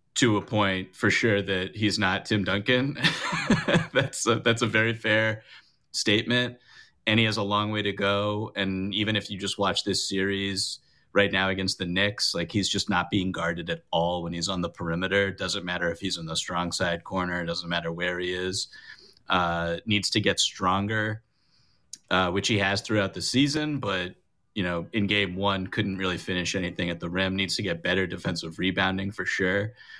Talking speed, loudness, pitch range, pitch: 200 wpm, -26 LUFS, 90-105 Hz, 100 Hz